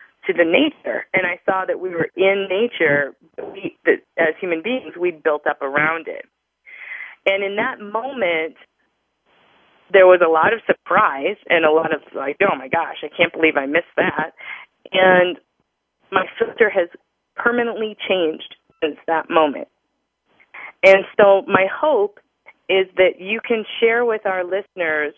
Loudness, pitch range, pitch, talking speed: -18 LUFS, 165-225 Hz, 190 Hz, 160 wpm